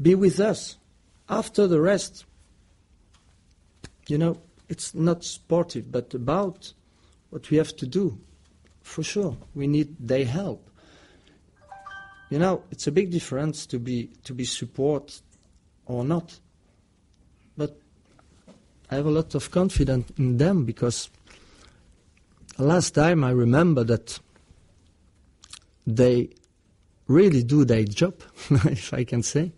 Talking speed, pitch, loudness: 125 wpm, 130 Hz, -24 LUFS